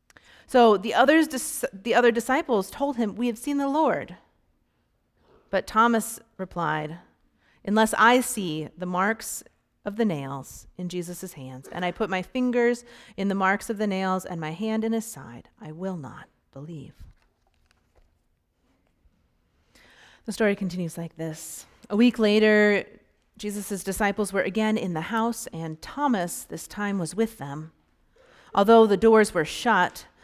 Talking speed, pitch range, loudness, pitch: 150 wpm, 170-230 Hz, -24 LUFS, 205 Hz